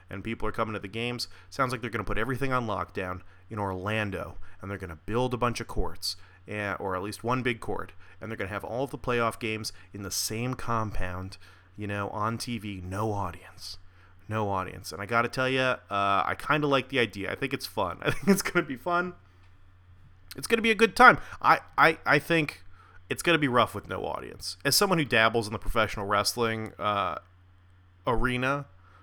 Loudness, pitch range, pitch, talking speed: -28 LUFS, 95-120 Hz, 105 Hz, 215 wpm